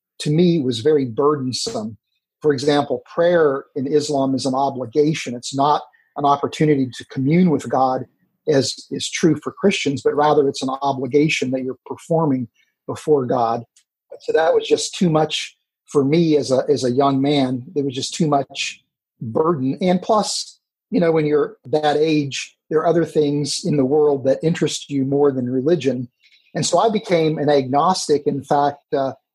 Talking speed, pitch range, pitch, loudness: 175 wpm, 135-155 Hz, 145 Hz, -19 LUFS